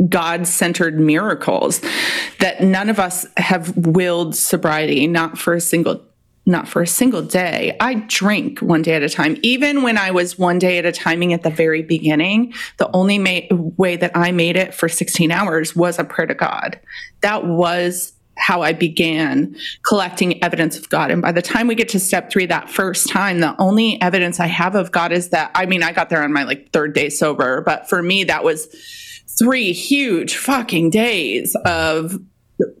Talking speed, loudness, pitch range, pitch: 190 wpm, -16 LUFS, 170-200 Hz, 180 Hz